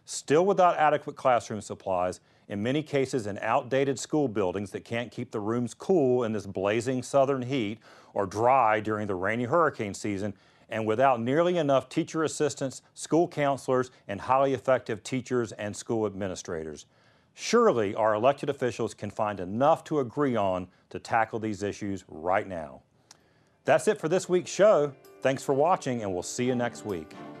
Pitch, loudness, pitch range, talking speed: 125 Hz, -27 LUFS, 105-140 Hz, 165 wpm